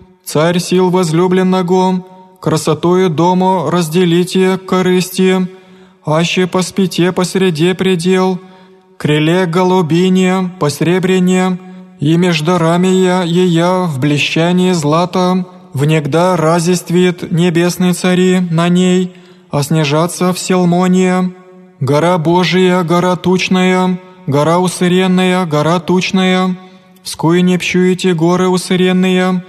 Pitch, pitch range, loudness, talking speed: 180 Hz, 175-185 Hz, -12 LUFS, 95 wpm